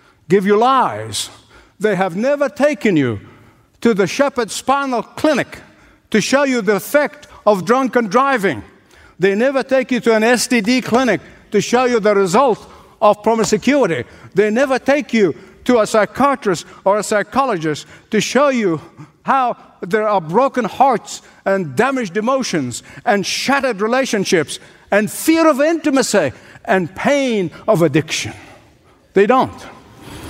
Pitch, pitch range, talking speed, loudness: 220 Hz, 195-260 Hz, 140 wpm, -16 LUFS